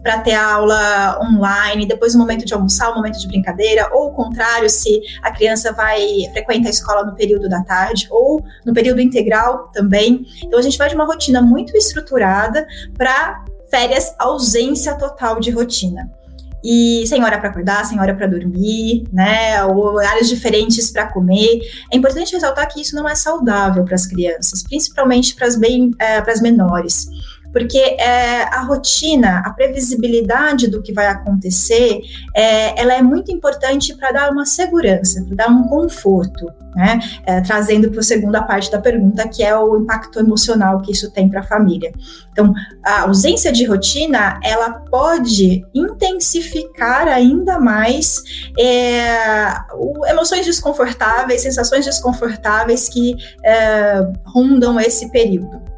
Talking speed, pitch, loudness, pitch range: 150 wpm, 230 Hz, -13 LUFS, 205-255 Hz